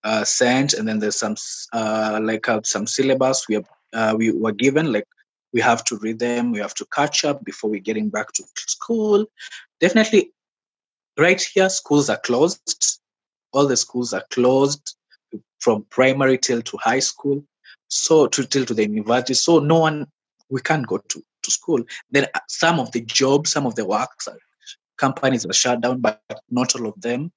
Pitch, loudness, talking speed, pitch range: 125 Hz, -20 LUFS, 190 wpm, 110-140 Hz